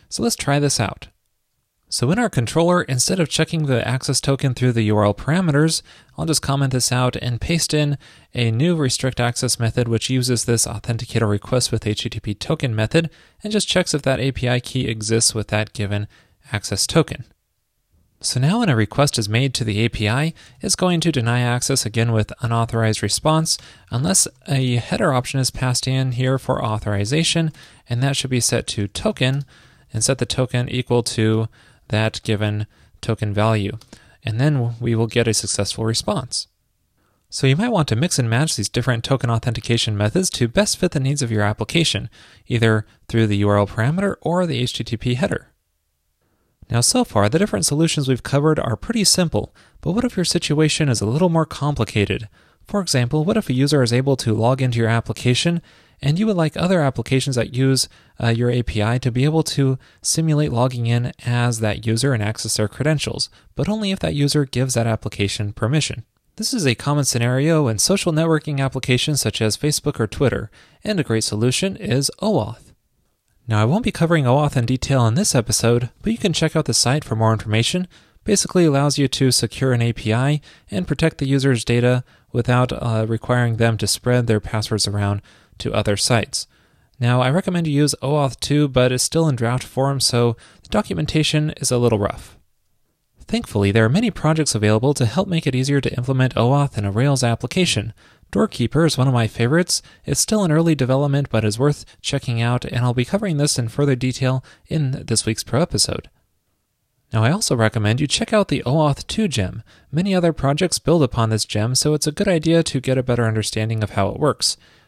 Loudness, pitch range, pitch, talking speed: -19 LUFS, 110-150 Hz, 125 Hz, 195 wpm